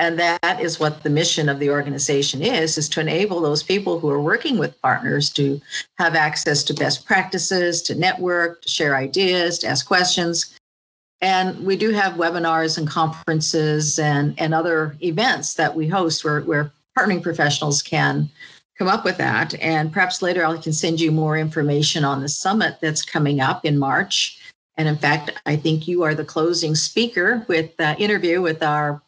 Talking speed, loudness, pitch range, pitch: 185 wpm, -20 LUFS, 150-175 Hz, 160 Hz